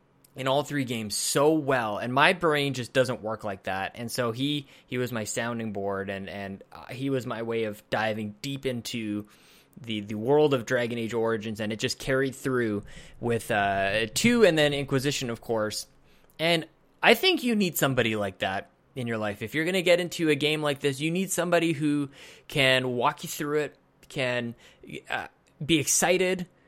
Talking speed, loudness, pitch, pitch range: 195 wpm, -27 LUFS, 130 Hz, 110-150 Hz